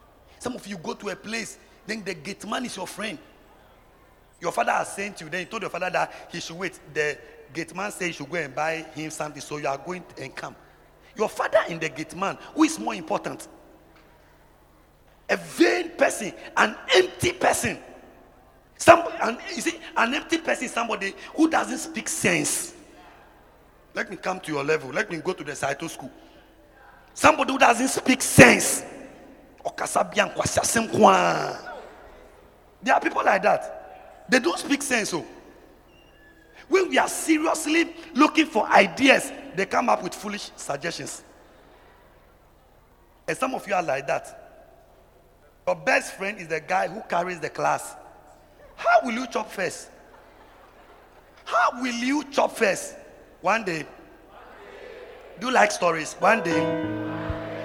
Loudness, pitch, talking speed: -24 LUFS, 200 Hz, 160 wpm